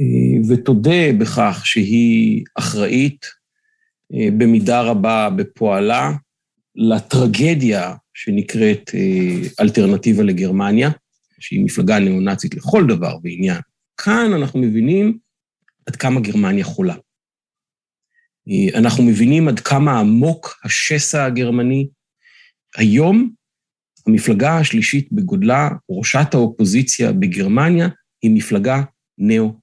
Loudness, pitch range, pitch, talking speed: -16 LUFS, 115-195 Hz, 150 Hz, 85 wpm